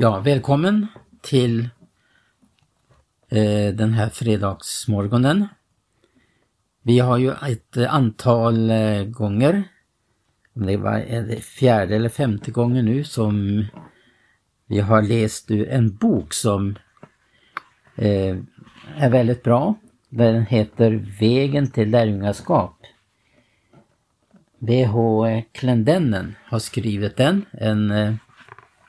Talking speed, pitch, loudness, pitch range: 100 wpm, 115 Hz, -20 LUFS, 105-130 Hz